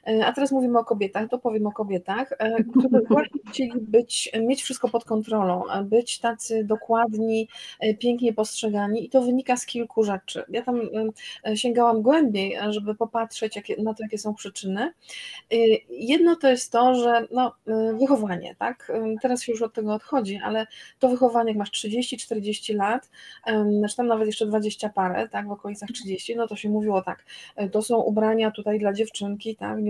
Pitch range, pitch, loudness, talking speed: 215-245 Hz, 225 Hz, -24 LUFS, 165 wpm